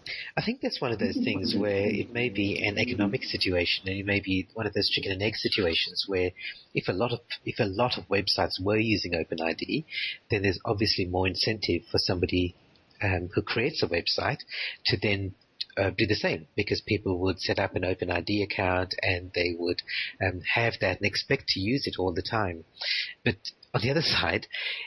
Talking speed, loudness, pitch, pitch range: 210 wpm, -28 LUFS, 100 Hz, 90-110 Hz